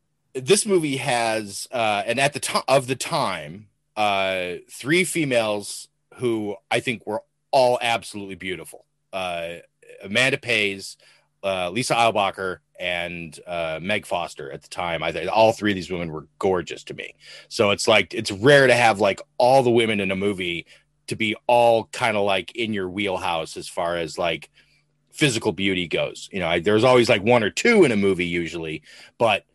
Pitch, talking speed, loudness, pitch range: 110 Hz, 185 wpm, -21 LUFS, 95-130 Hz